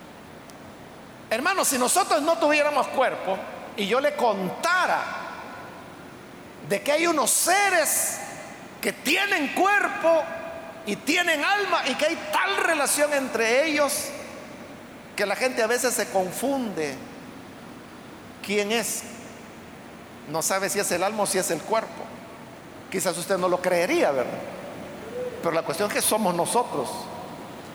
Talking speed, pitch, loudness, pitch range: 130 wpm, 255 Hz, -24 LUFS, 205-310 Hz